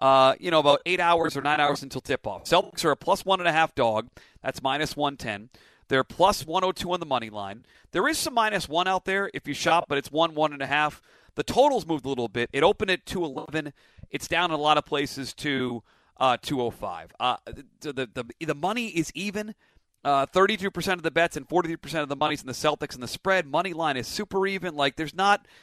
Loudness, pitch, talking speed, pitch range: -26 LUFS, 150 Hz, 235 wpm, 135-180 Hz